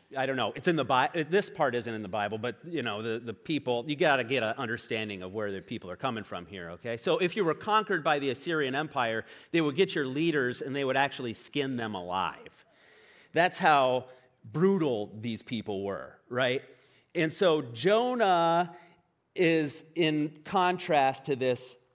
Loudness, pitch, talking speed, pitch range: -29 LUFS, 135 Hz, 190 wpm, 120-165 Hz